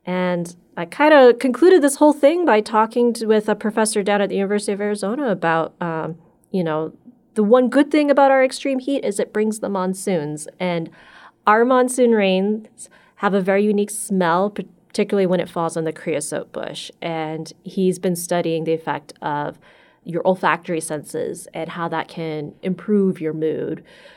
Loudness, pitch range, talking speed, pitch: -19 LUFS, 170-220 Hz, 175 wpm, 195 Hz